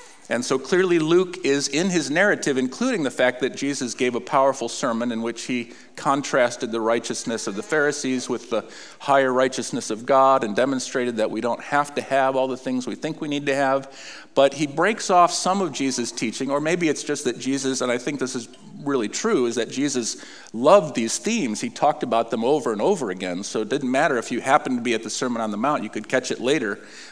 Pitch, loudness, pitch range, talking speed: 135 Hz, -22 LUFS, 120-145 Hz, 230 wpm